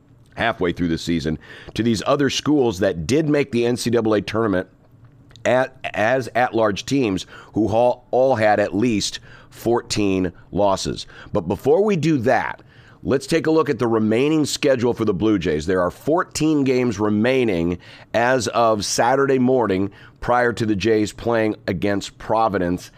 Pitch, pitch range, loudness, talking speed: 120 Hz, 105-130 Hz, -20 LUFS, 155 wpm